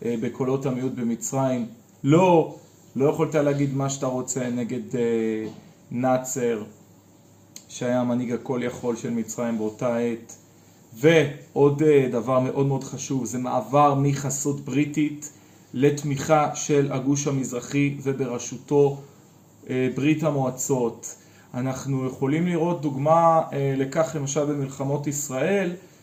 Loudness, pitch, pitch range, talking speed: -24 LUFS, 135 Hz, 125-150 Hz, 100 wpm